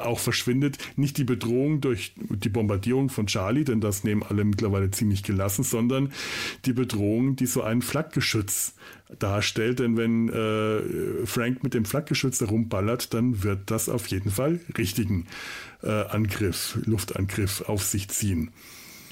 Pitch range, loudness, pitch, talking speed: 105-125 Hz, -26 LUFS, 115 Hz, 145 wpm